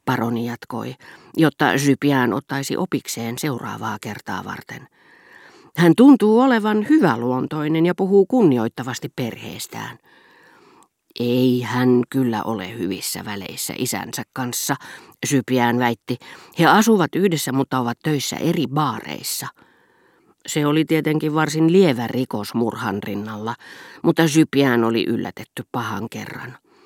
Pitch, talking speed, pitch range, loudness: 130 Hz, 110 wpm, 120-160 Hz, -20 LUFS